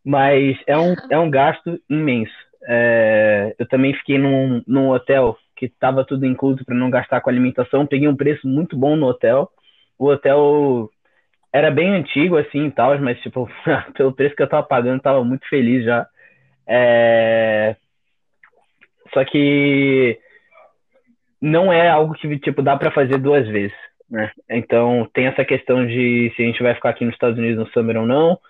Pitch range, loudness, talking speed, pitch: 120-145 Hz, -17 LUFS, 175 wpm, 135 Hz